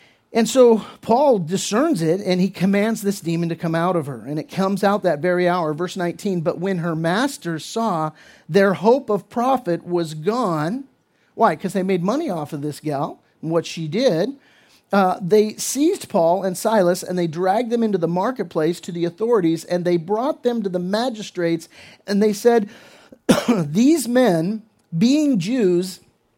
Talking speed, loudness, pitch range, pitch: 175 wpm, -20 LUFS, 170-225 Hz, 190 Hz